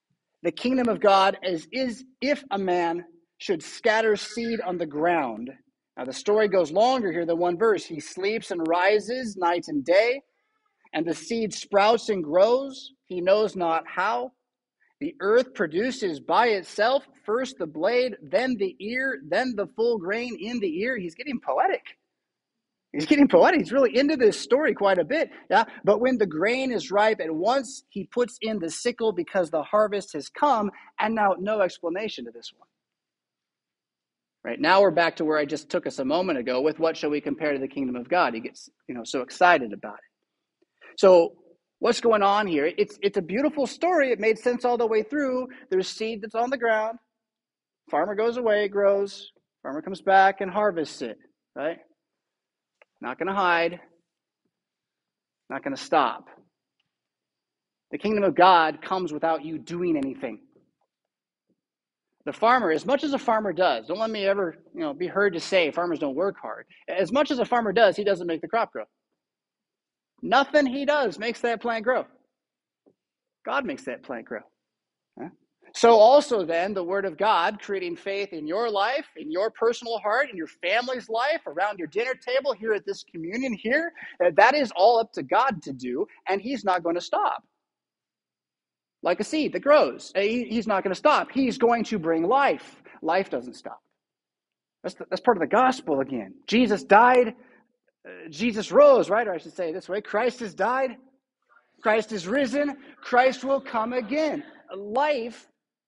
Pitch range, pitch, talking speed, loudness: 185-260 Hz, 220 Hz, 180 wpm, -24 LUFS